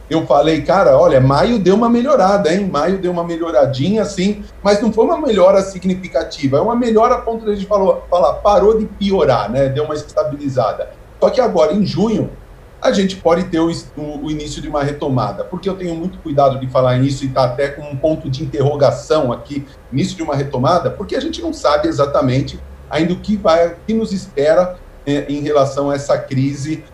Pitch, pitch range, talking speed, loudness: 160 Hz, 140-195 Hz, 205 wpm, -15 LUFS